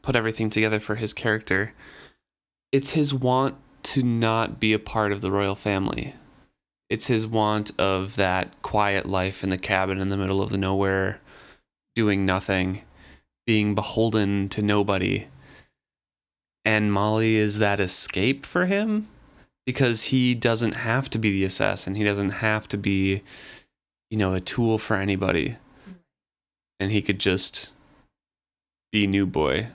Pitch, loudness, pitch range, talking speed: 105 Hz, -23 LUFS, 95-115 Hz, 145 wpm